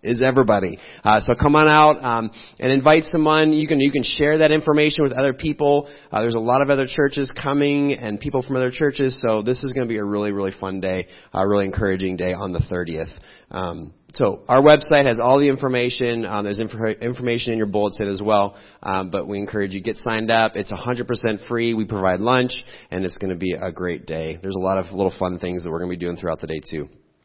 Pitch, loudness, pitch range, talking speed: 115 Hz, -20 LUFS, 95-135 Hz, 240 wpm